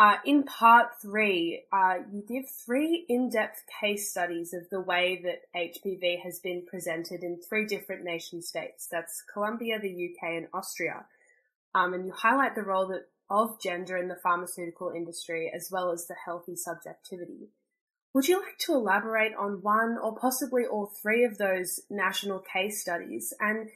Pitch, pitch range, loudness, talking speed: 190 Hz, 175-220 Hz, -29 LUFS, 165 wpm